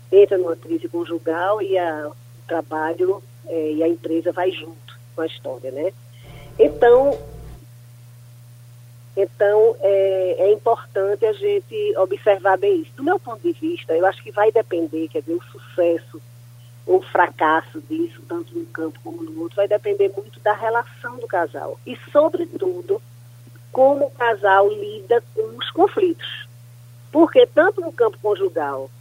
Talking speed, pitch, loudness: 150 wpm, 190 Hz, -20 LUFS